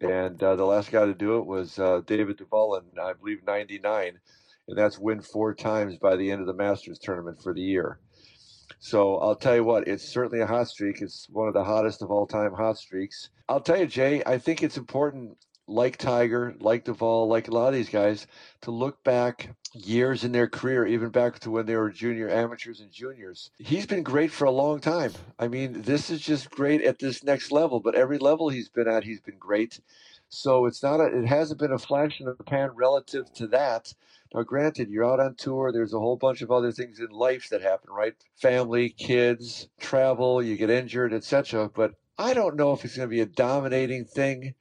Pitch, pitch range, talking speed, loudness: 120 Hz, 110-135 Hz, 220 wpm, -26 LUFS